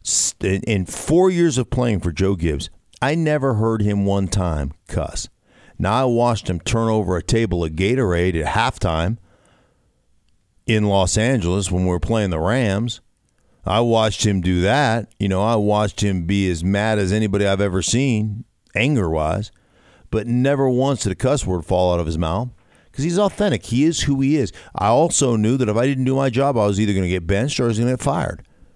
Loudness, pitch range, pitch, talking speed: -19 LUFS, 90-125 Hz, 105 Hz, 210 wpm